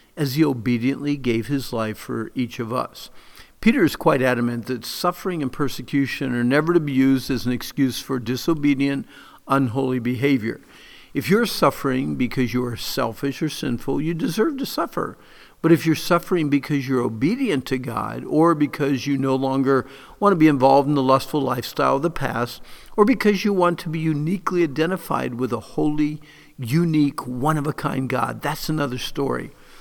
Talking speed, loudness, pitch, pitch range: 175 wpm, -22 LUFS, 140 Hz, 130-160 Hz